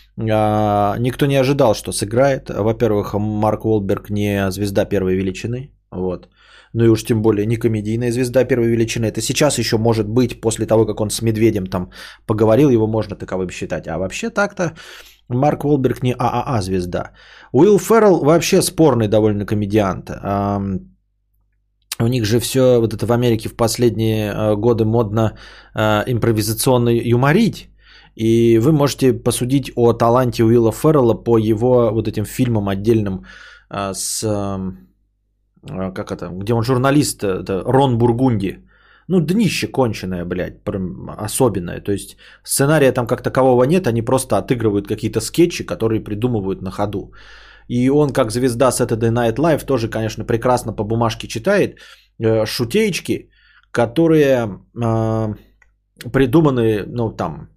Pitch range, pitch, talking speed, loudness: 105-125 Hz, 115 Hz, 140 wpm, -17 LUFS